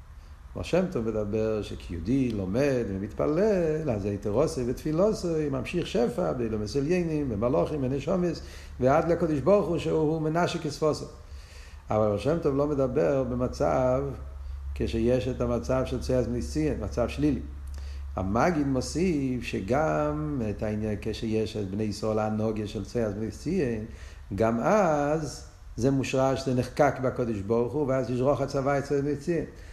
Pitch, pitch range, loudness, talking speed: 125 Hz, 110-145 Hz, -27 LUFS, 135 wpm